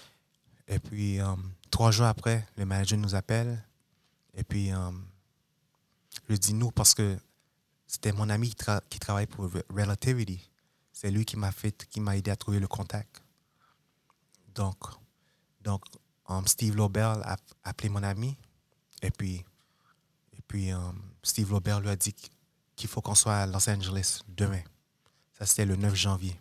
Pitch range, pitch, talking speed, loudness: 100-115 Hz, 105 Hz, 160 wpm, -29 LUFS